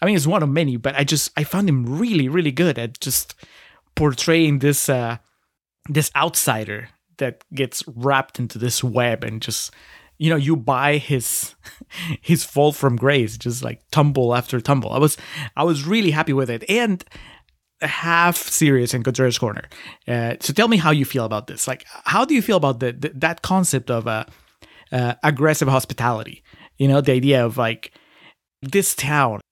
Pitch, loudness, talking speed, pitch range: 140 Hz, -20 LUFS, 180 wpm, 125-160 Hz